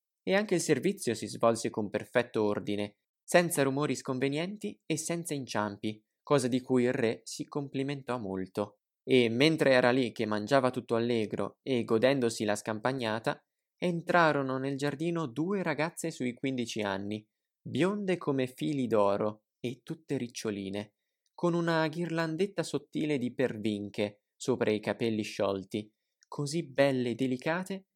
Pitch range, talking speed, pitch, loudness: 110-155 Hz, 135 wpm, 130 Hz, -31 LUFS